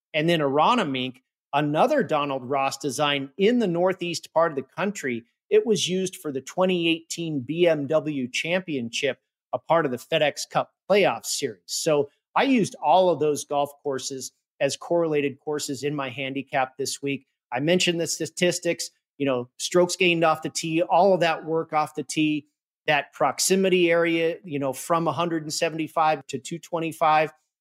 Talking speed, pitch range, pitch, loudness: 160 wpm, 140-170 Hz, 155 Hz, -24 LUFS